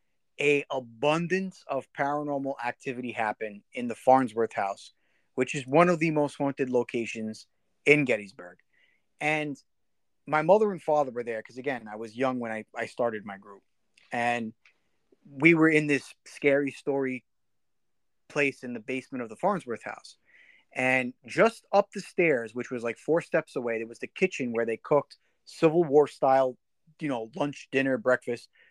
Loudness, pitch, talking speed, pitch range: -27 LUFS, 135 Hz, 165 wpm, 120-150 Hz